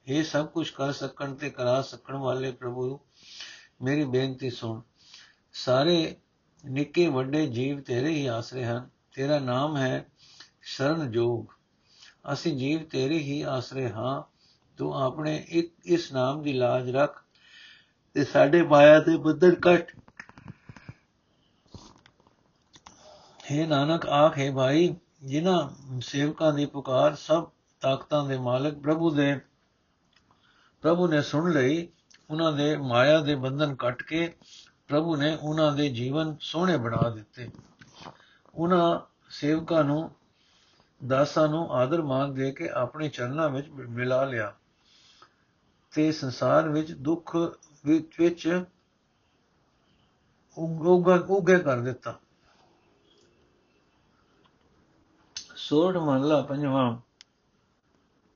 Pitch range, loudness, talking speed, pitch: 130-160 Hz, -26 LUFS, 110 wpm, 145 Hz